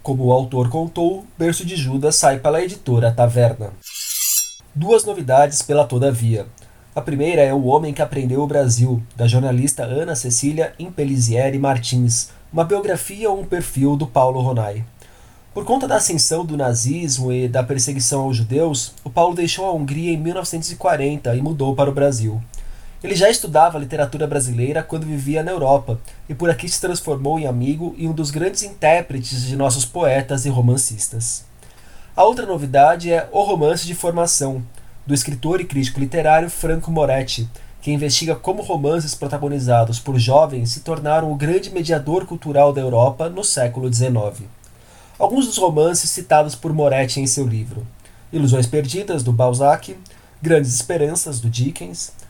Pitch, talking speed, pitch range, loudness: 140 Hz, 160 wpm, 125-165 Hz, -18 LUFS